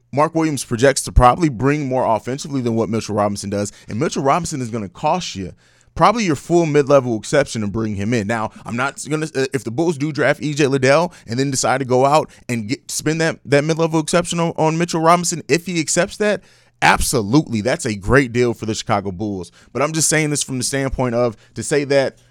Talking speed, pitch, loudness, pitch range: 225 wpm, 135 Hz, -18 LUFS, 115-155 Hz